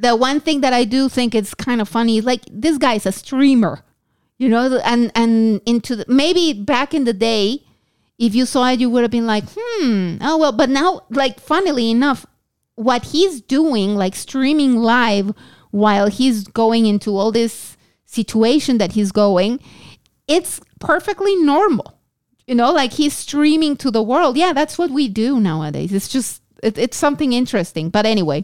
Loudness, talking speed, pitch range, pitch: -16 LUFS, 180 wpm, 220-290 Hz, 245 Hz